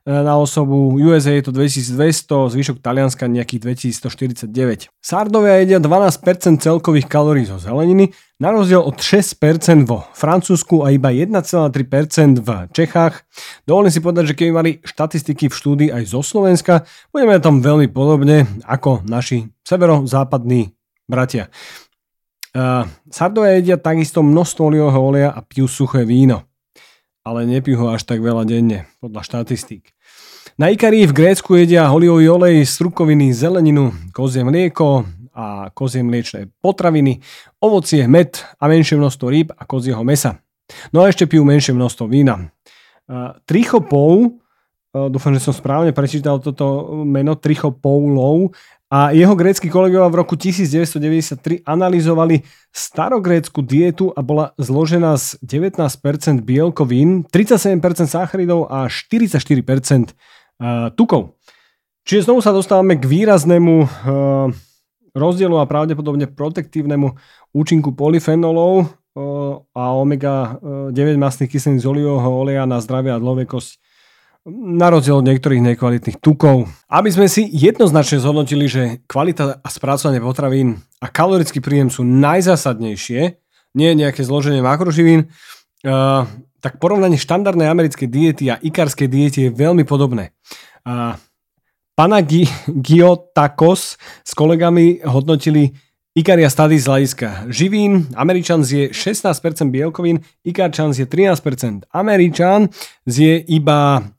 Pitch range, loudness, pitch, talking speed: 130-170 Hz, -14 LUFS, 145 Hz, 120 wpm